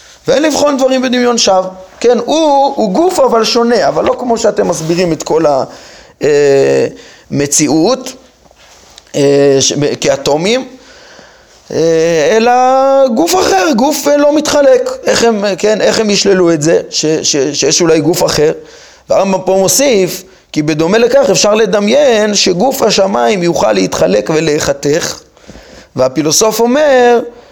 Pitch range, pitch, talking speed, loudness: 170-265 Hz, 220 Hz, 120 wpm, -10 LUFS